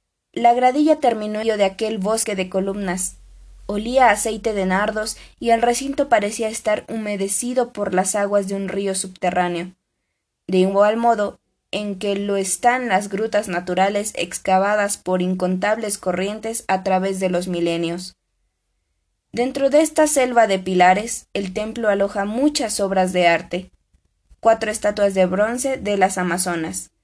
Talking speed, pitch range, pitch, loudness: 145 wpm, 185-225 Hz, 205 Hz, -20 LUFS